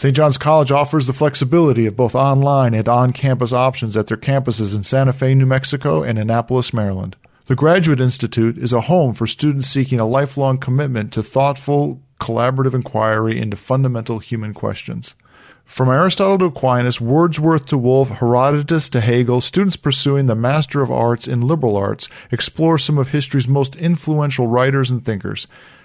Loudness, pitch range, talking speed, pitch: -16 LUFS, 120-145 Hz, 165 wpm, 130 Hz